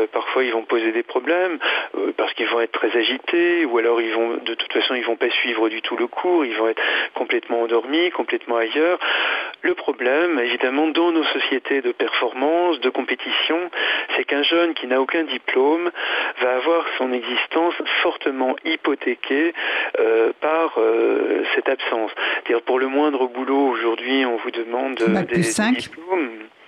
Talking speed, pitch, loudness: 175 wpm, 160 Hz, -20 LUFS